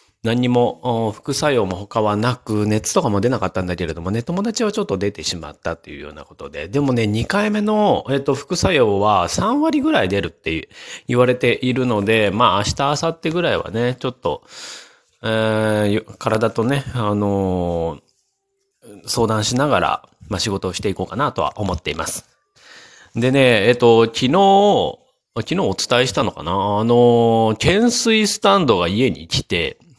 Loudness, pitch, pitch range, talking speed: -18 LUFS, 120 Hz, 105-140 Hz, 310 characters per minute